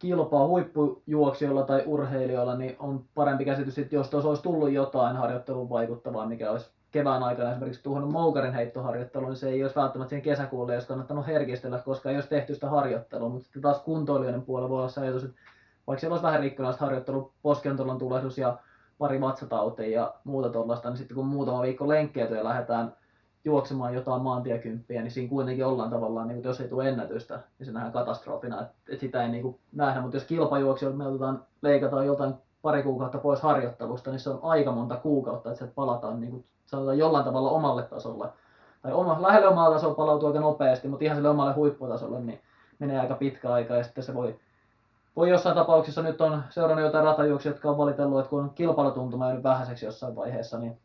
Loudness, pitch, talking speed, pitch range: -28 LUFS, 135 Hz, 190 wpm, 125-145 Hz